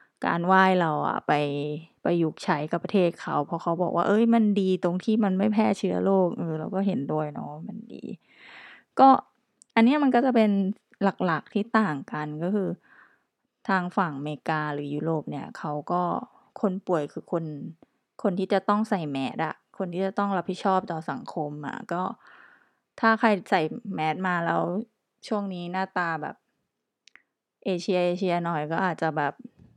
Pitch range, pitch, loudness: 160-205 Hz, 185 Hz, -26 LUFS